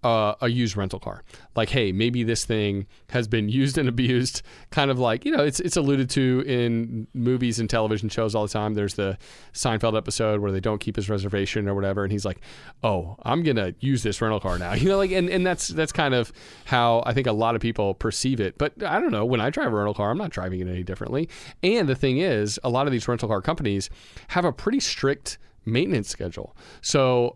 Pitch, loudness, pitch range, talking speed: 115 Hz, -24 LUFS, 105-130 Hz, 250 wpm